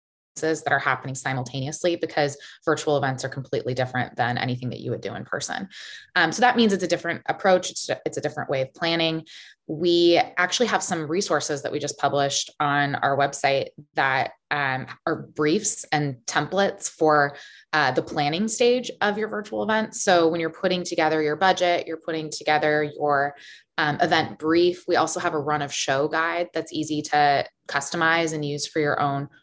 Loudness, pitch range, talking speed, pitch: -23 LUFS, 145-175 Hz, 185 wpm, 155 Hz